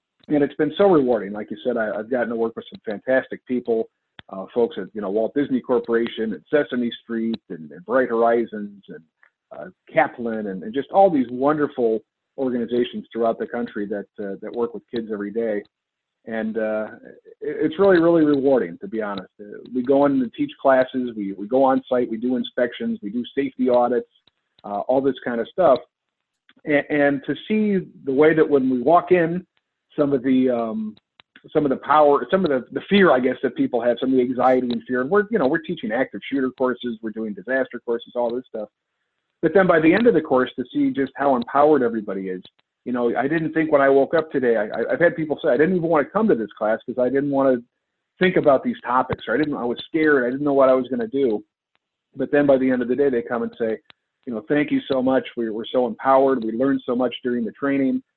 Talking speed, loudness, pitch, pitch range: 235 wpm, -21 LUFS, 130 Hz, 115-145 Hz